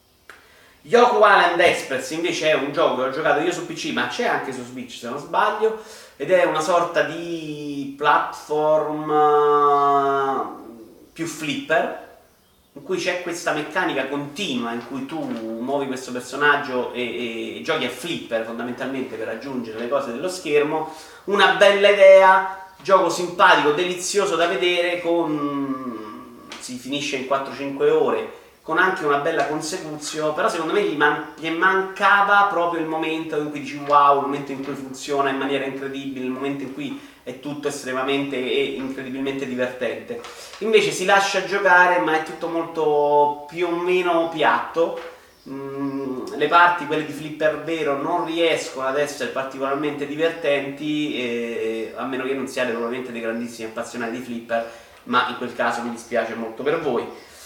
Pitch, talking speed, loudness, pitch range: 145 Hz, 160 wpm, -21 LUFS, 130-170 Hz